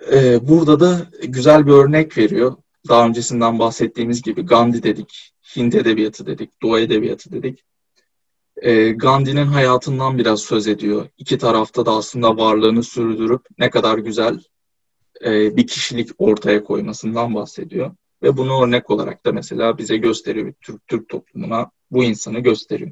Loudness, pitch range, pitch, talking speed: -16 LUFS, 110-130 Hz, 120 Hz, 135 wpm